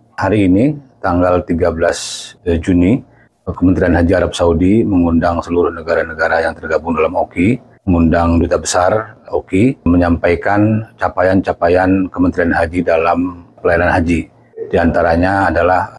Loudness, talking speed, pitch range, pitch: -14 LUFS, 115 wpm, 85-100 Hz, 90 Hz